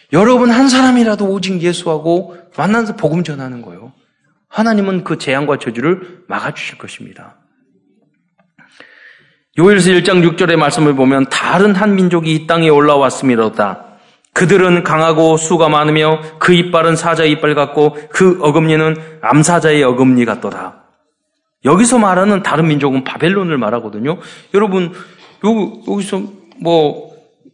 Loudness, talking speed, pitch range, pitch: -12 LUFS, 295 characters per minute, 150-190 Hz, 165 Hz